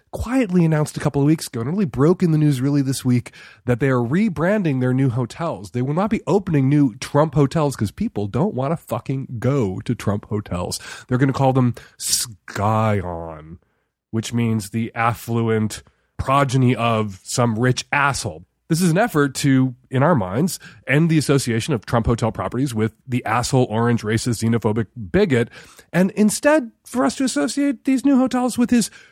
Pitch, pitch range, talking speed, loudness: 130 Hz, 115-160 Hz, 185 wpm, -20 LUFS